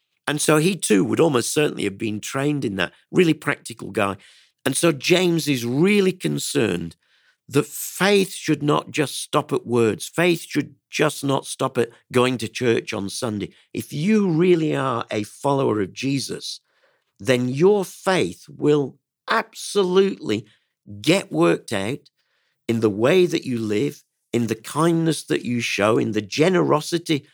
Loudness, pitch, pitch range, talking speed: -21 LUFS, 140 Hz, 115-165 Hz, 155 wpm